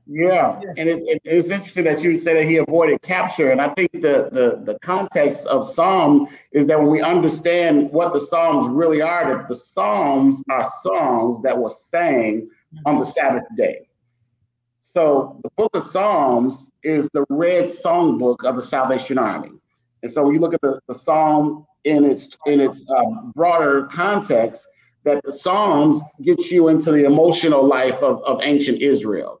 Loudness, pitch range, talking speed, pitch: -18 LUFS, 135-175 Hz, 180 wpm, 155 Hz